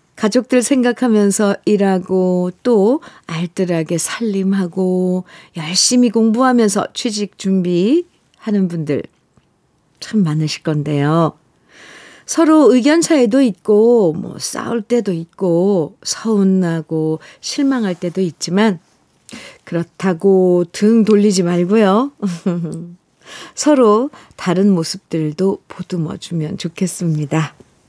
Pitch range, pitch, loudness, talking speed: 170-220 Hz, 190 Hz, -15 LUFS, 215 characters per minute